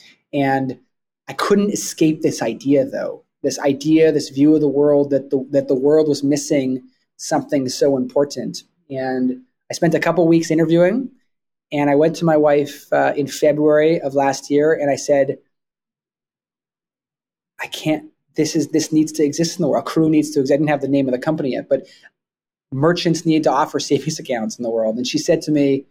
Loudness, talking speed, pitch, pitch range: -18 LUFS, 195 wpm, 145 Hz, 140-155 Hz